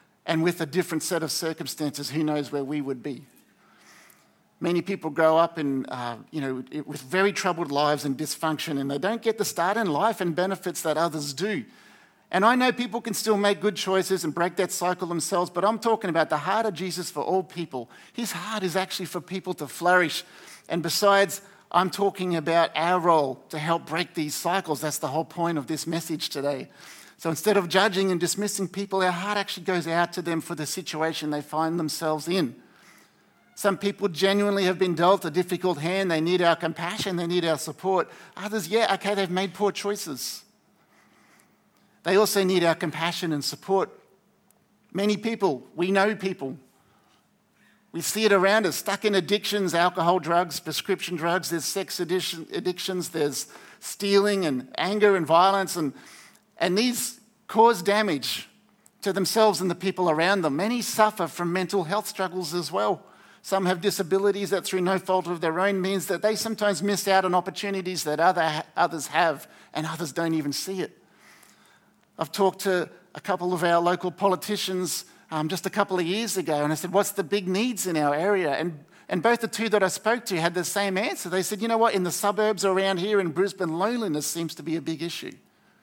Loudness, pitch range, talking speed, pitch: -25 LUFS, 165-200 Hz, 195 wpm, 185 Hz